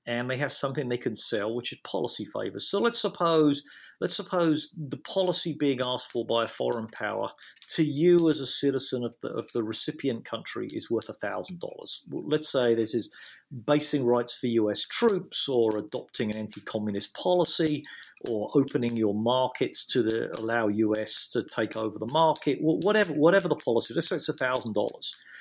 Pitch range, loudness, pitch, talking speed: 115-155 Hz, -27 LUFS, 135 Hz, 180 wpm